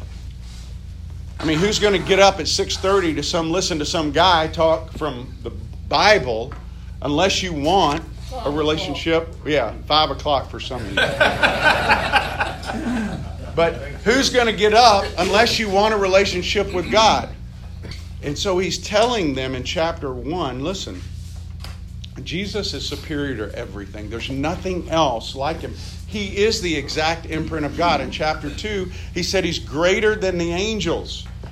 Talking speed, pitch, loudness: 150 wpm, 155 Hz, -19 LUFS